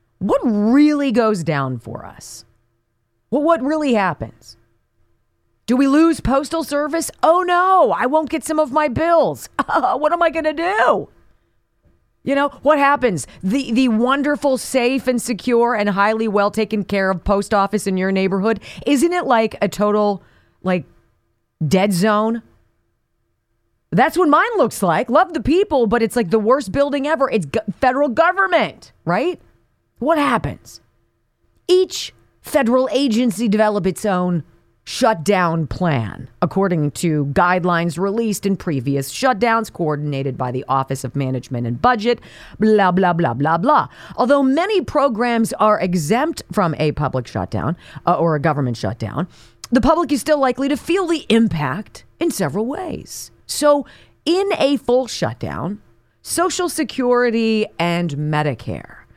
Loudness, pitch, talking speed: -18 LUFS, 220 Hz, 145 wpm